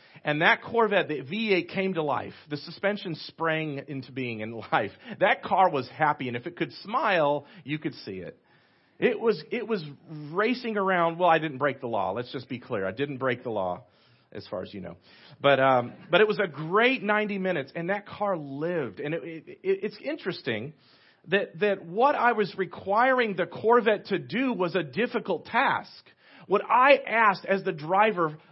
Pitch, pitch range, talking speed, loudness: 170 Hz, 145-205 Hz, 195 wpm, -26 LUFS